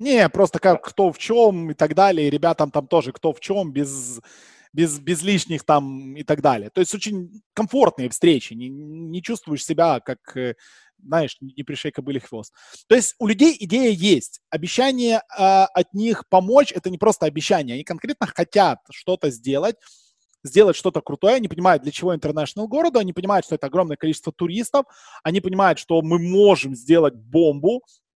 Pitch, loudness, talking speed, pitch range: 175 Hz, -20 LUFS, 170 wpm, 150-205 Hz